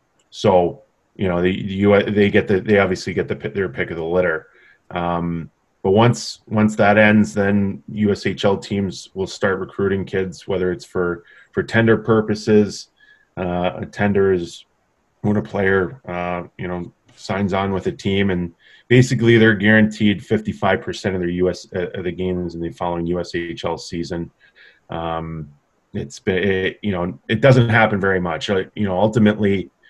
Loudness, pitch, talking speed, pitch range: -19 LUFS, 100 Hz, 170 wpm, 90-105 Hz